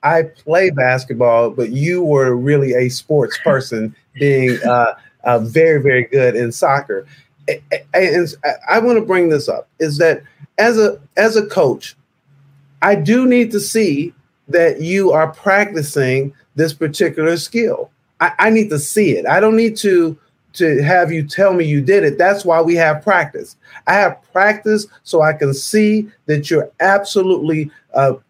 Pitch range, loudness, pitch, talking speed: 140-200 Hz, -15 LUFS, 160 Hz, 165 wpm